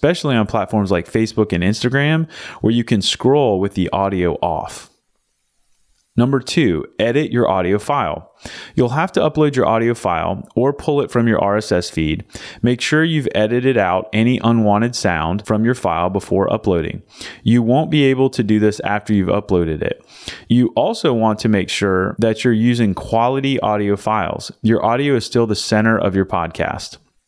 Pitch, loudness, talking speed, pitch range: 110 Hz, -17 LUFS, 175 wpm, 100-125 Hz